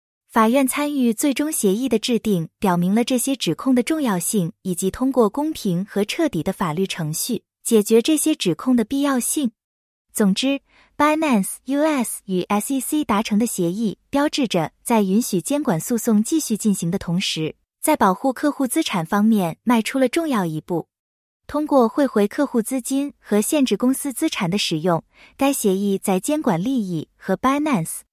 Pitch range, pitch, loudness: 195-275 Hz, 230 Hz, -20 LUFS